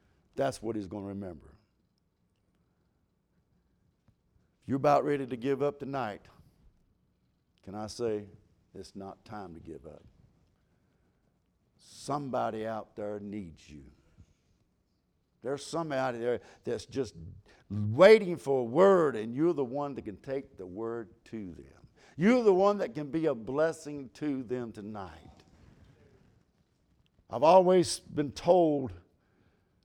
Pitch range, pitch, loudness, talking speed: 95-145 Hz, 115 Hz, -29 LUFS, 125 wpm